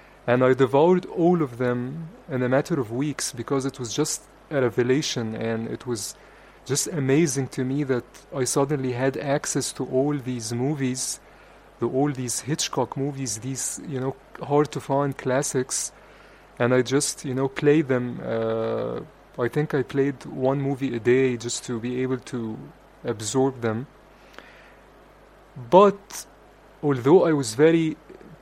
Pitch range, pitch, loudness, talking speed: 125-145 Hz, 135 Hz, -24 LUFS, 150 wpm